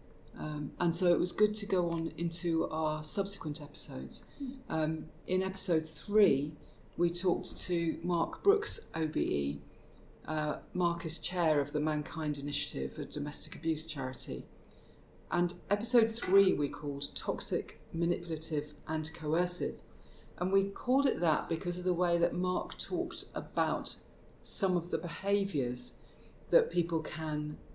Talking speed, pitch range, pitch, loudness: 140 wpm, 150-180 Hz, 165 Hz, -31 LUFS